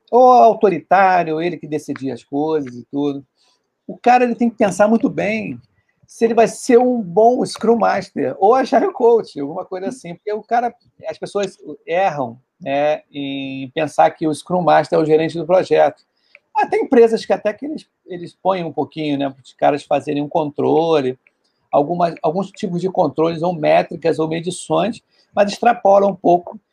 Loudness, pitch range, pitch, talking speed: -17 LUFS, 150-215 Hz, 180 Hz, 175 wpm